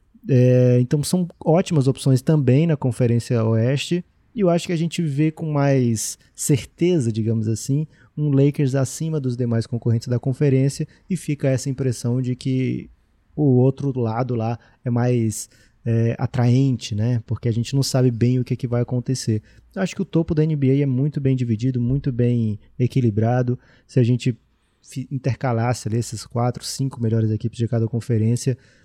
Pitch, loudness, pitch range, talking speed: 125 Hz, -21 LUFS, 115-140 Hz, 175 wpm